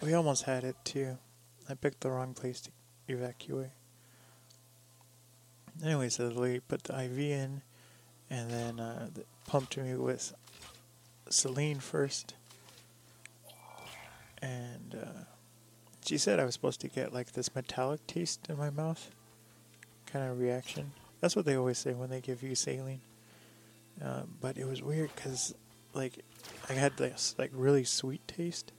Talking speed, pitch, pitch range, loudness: 145 wpm, 125 Hz, 120-135 Hz, -36 LUFS